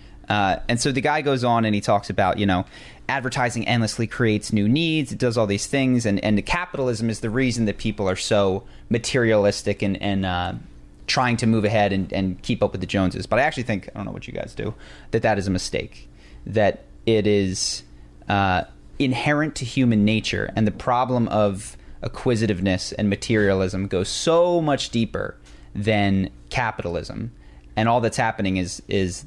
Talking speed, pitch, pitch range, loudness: 195 wpm, 105 Hz, 95-120 Hz, -22 LUFS